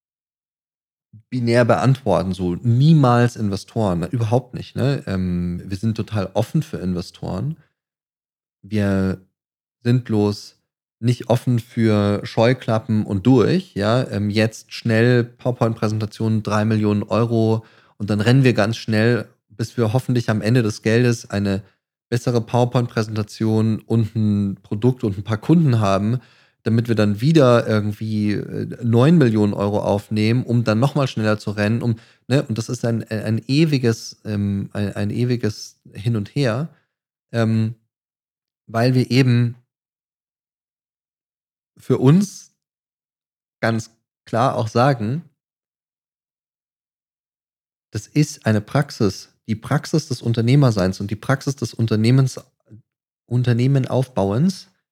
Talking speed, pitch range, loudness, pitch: 120 wpm, 105-125 Hz, -20 LUFS, 115 Hz